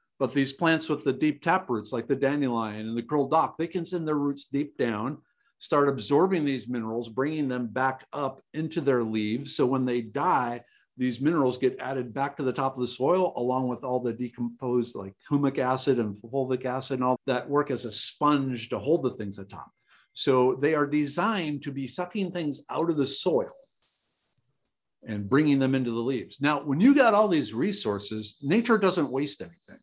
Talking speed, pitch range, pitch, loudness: 205 wpm, 125-150 Hz, 135 Hz, -27 LUFS